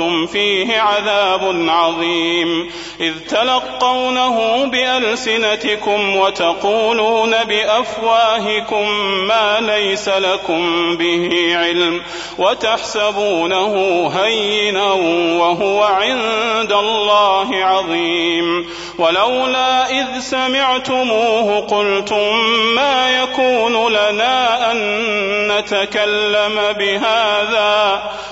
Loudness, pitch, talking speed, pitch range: -15 LUFS, 210 Hz, 60 wpm, 190-225 Hz